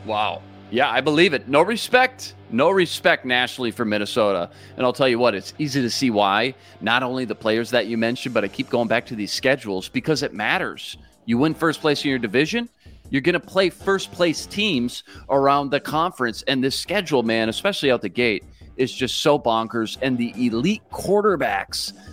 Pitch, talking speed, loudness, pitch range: 125 Hz, 200 wpm, -21 LUFS, 110-145 Hz